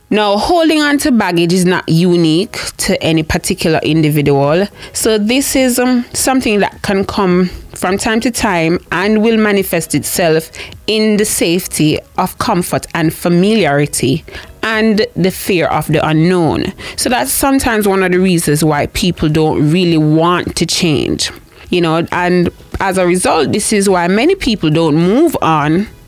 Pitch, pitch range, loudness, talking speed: 180 Hz, 160-215 Hz, -12 LUFS, 160 wpm